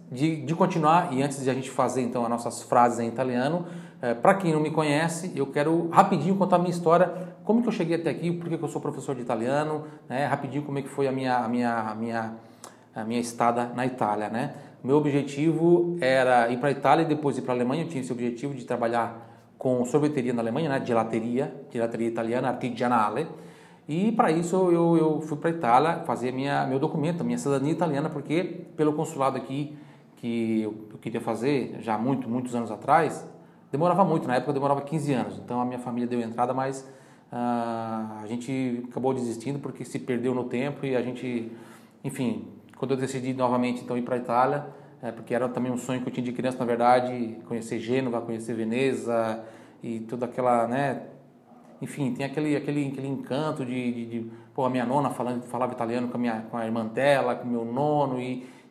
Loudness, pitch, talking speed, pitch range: -27 LUFS, 130 Hz, 205 wpm, 120-145 Hz